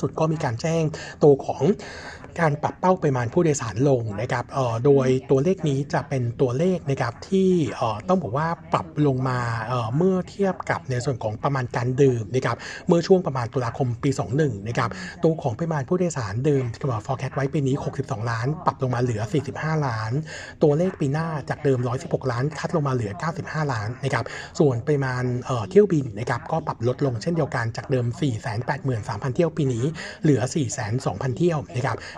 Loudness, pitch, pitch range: -24 LUFS, 140 Hz, 125-155 Hz